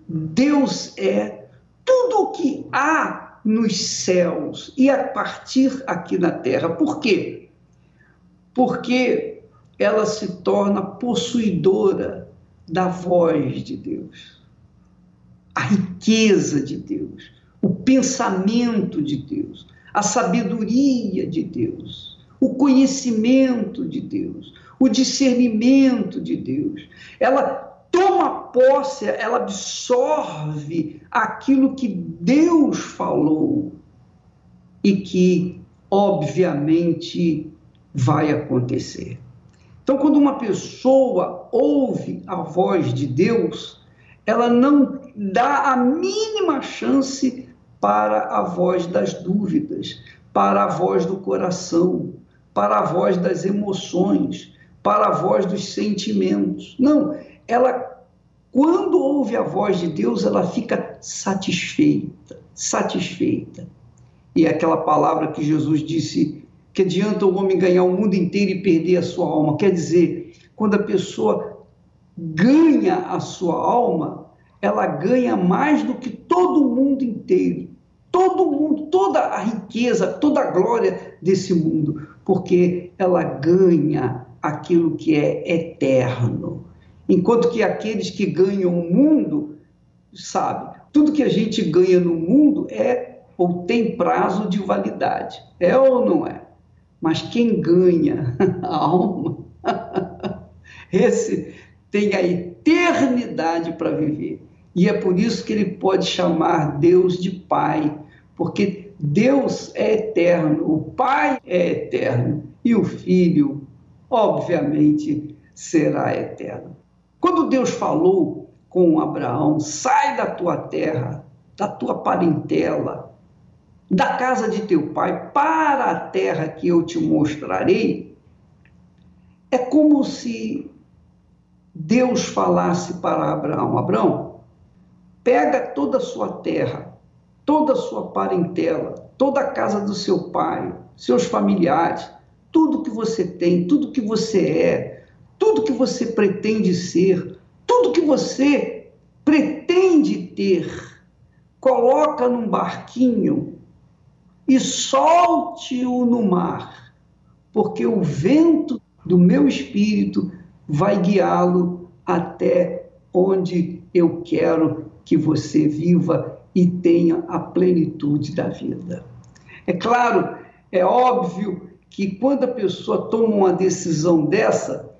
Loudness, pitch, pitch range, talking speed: -19 LUFS, 200 Hz, 175-265 Hz, 110 wpm